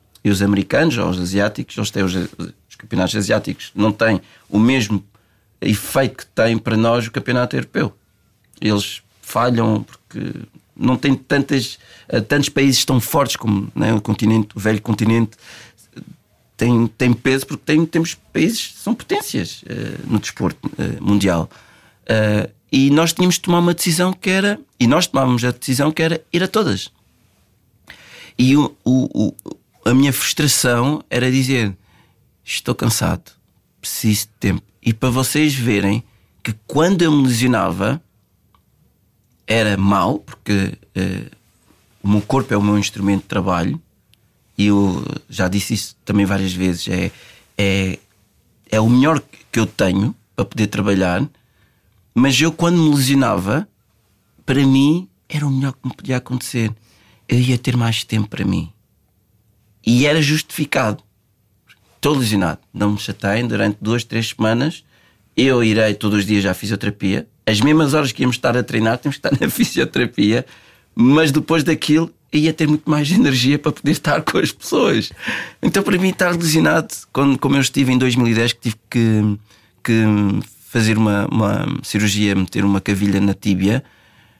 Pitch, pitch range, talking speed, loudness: 115 Hz, 105-140 Hz, 155 wpm, -17 LUFS